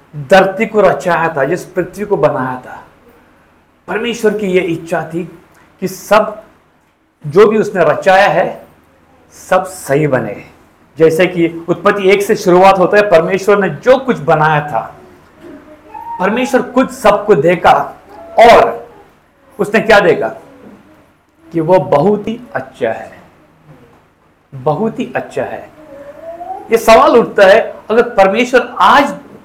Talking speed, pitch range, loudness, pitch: 130 wpm, 165-225 Hz, -11 LUFS, 195 Hz